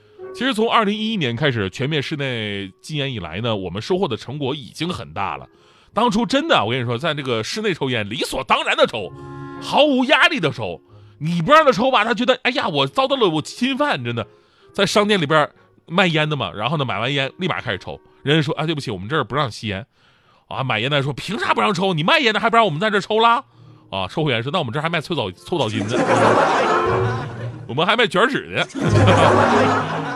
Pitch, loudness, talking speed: 150 Hz, -19 LUFS, 320 characters per minute